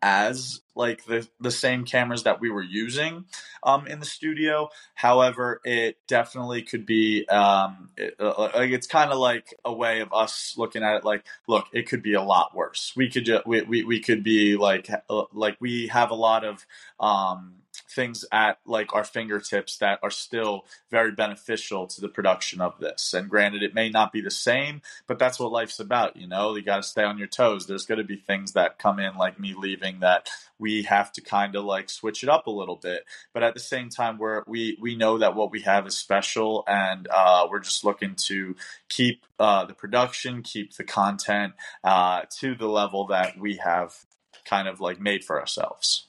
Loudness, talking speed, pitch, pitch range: -25 LUFS, 210 wpm, 110 Hz, 100-120 Hz